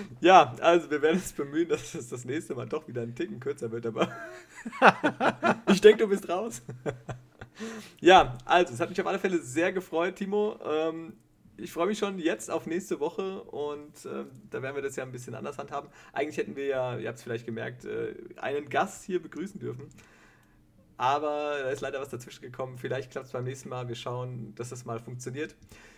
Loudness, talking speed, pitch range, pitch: -28 LUFS, 200 wpm, 125-185 Hz, 150 Hz